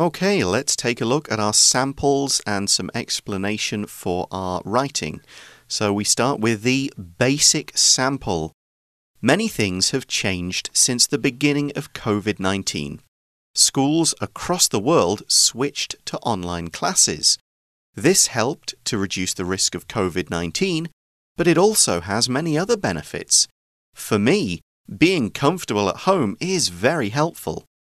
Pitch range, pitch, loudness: 95-140 Hz, 115 Hz, -19 LUFS